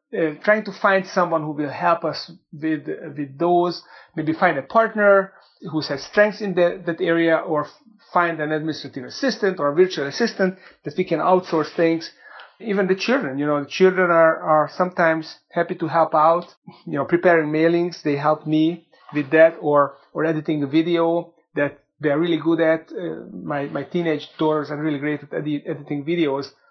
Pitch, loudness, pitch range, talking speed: 165 Hz, -21 LUFS, 150-175 Hz, 190 wpm